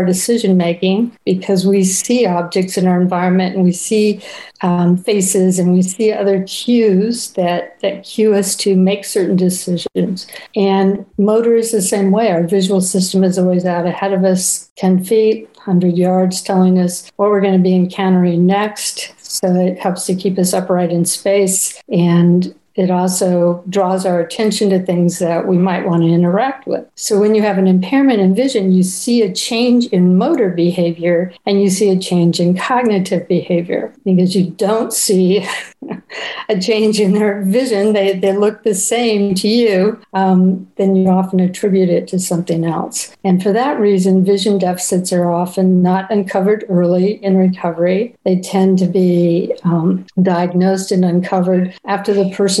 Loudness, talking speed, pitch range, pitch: -14 LUFS, 170 wpm, 180-205 Hz, 190 Hz